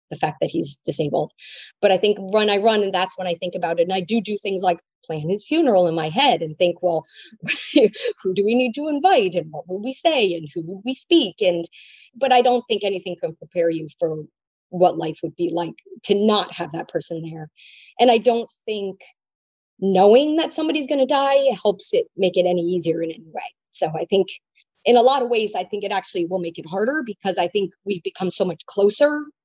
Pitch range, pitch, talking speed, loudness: 175-240 Hz, 195 Hz, 230 wpm, -21 LUFS